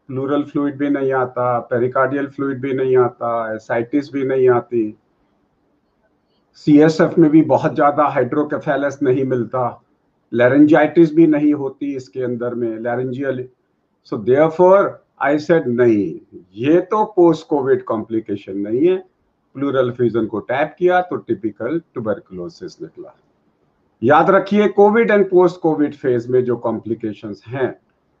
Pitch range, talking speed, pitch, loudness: 120-160 Hz, 130 wpm, 140 Hz, -17 LUFS